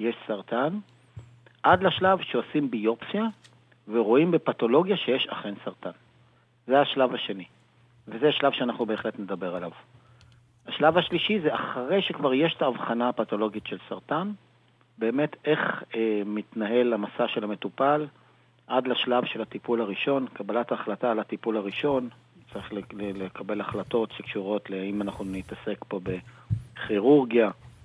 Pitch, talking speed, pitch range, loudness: 120 Hz, 125 wpm, 105-130 Hz, -27 LUFS